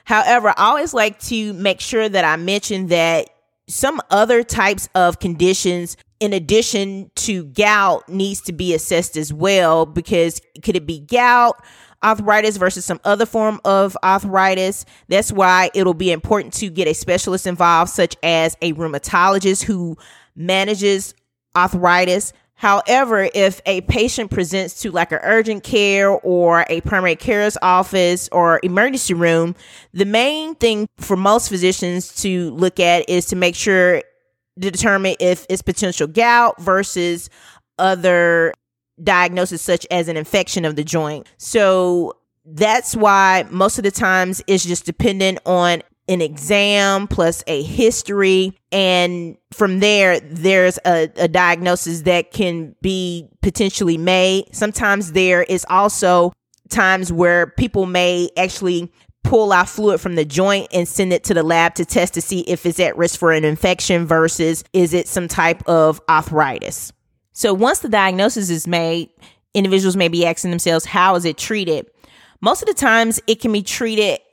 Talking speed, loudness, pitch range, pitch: 155 wpm, -16 LUFS, 175-200 Hz, 185 Hz